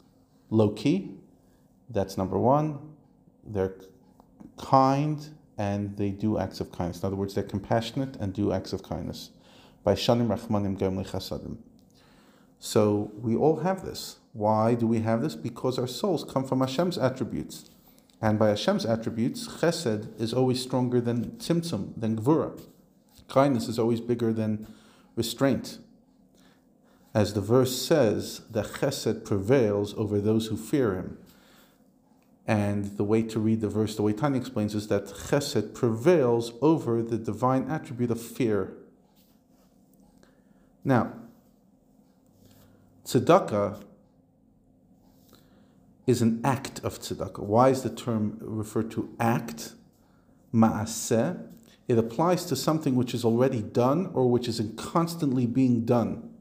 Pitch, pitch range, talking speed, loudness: 115 Hz, 105-130 Hz, 130 wpm, -27 LUFS